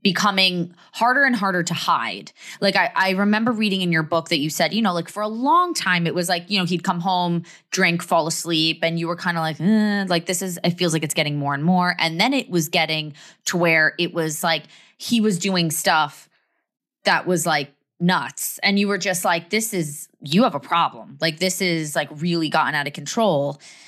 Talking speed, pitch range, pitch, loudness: 230 wpm, 165-195 Hz, 175 Hz, -20 LUFS